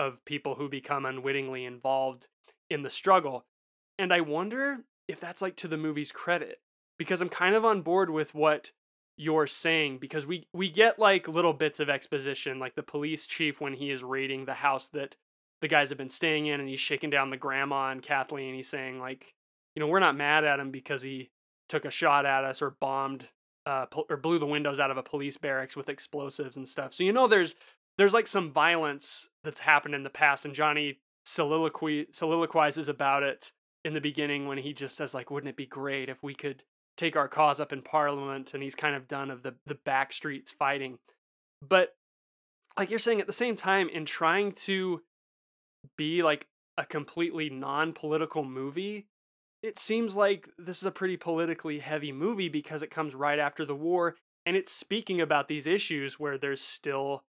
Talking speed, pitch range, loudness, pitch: 200 wpm, 140-170 Hz, -29 LUFS, 150 Hz